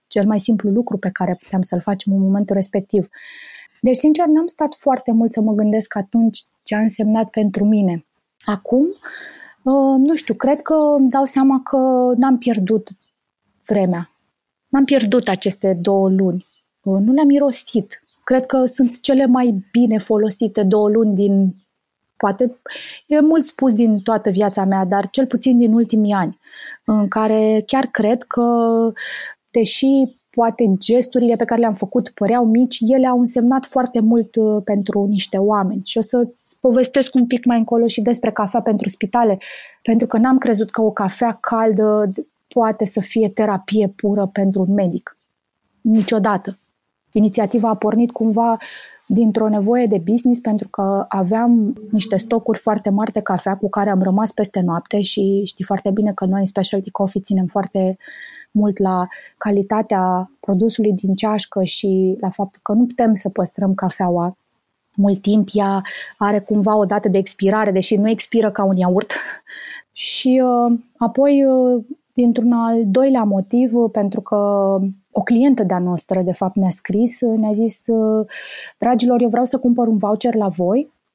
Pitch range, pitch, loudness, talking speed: 200-240 Hz, 220 Hz, -17 LUFS, 160 wpm